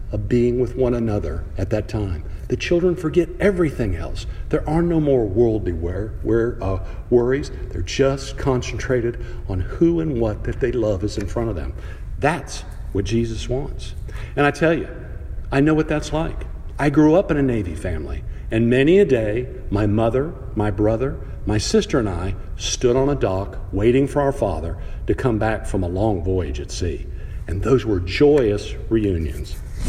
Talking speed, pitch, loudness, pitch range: 180 wpm, 110 Hz, -21 LUFS, 95-130 Hz